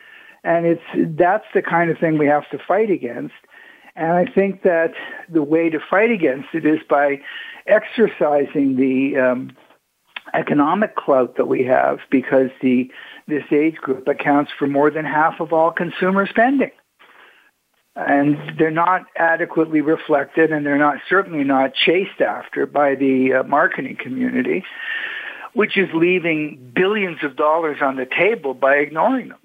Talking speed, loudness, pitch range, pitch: 155 wpm, -18 LUFS, 145-185 Hz, 160 Hz